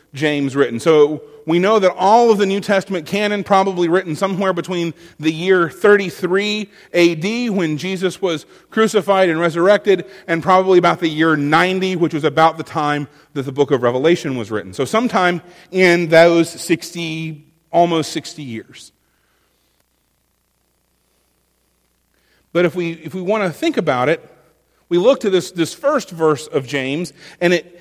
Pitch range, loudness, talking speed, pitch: 150-190 Hz, -16 LUFS, 160 wpm, 170 Hz